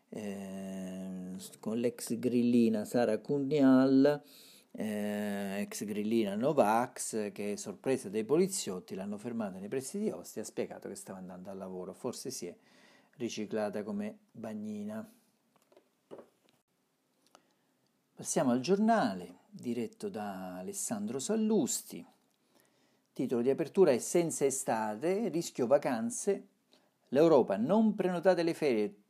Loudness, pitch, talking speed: -32 LUFS, 145 Hz, 110 wpm